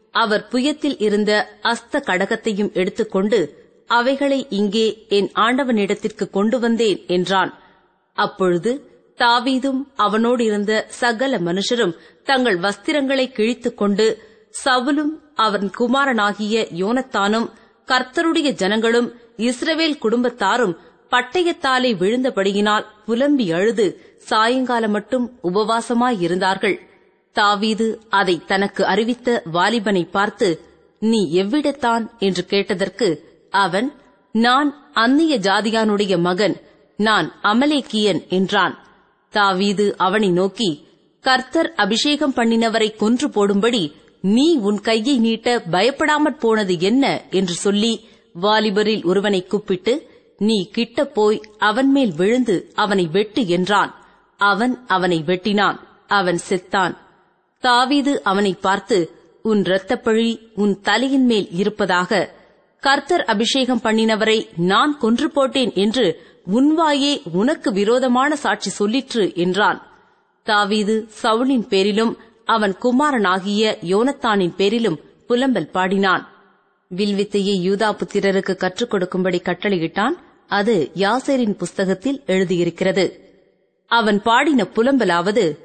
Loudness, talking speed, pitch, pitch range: -18 LUFS, 95 wpm, 220 Hz, 200-250 Hz